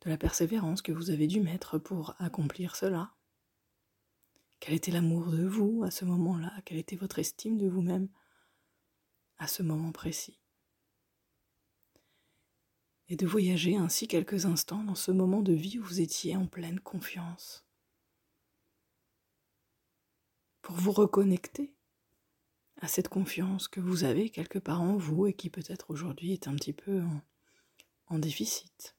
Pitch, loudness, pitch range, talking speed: 180 Hz, -32 LUFS, 165-195 Hz, 145 wpm